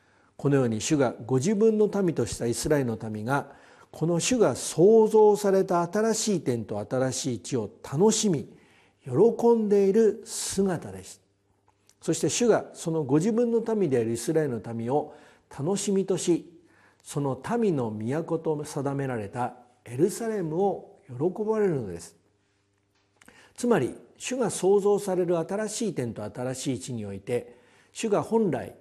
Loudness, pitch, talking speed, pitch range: -26 LUFS, 150 Hz, 275 characters per minute, 120-200 Hz